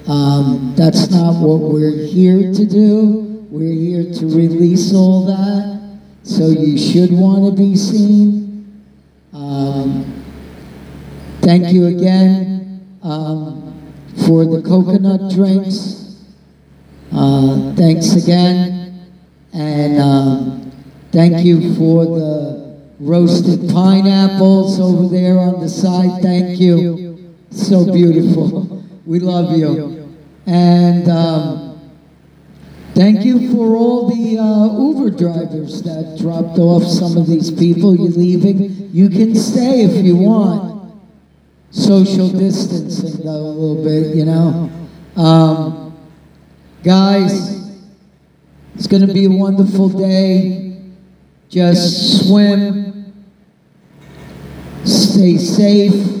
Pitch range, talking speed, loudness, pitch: 160-195 Hz, 105 wpm, -12 LUFS, 180 Hz